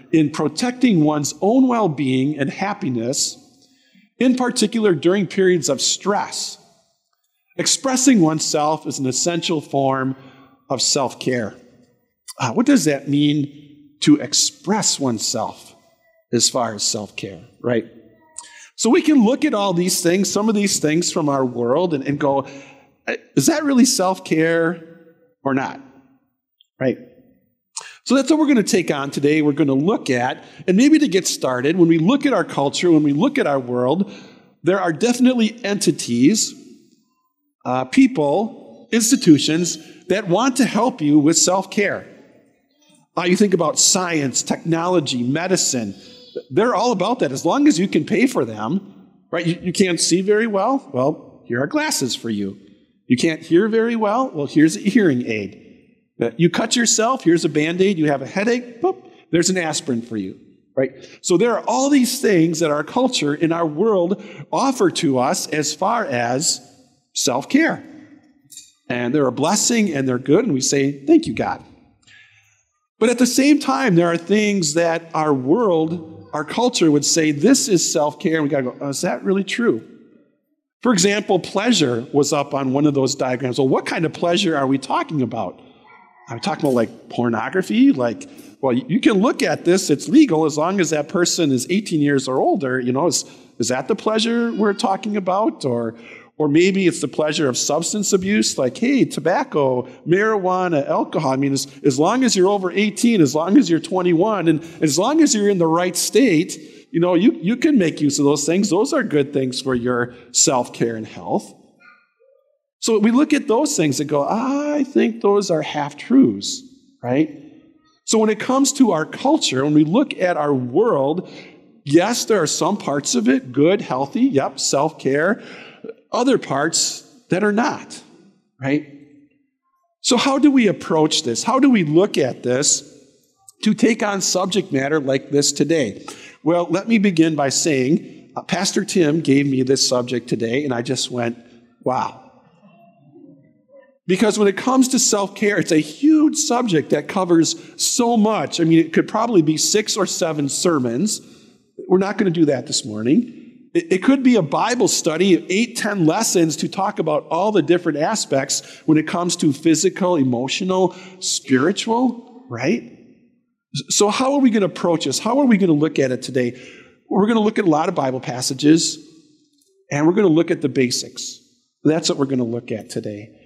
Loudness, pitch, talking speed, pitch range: -18 LUFS, 175 Hz, 180 wpm, 145-235 Hz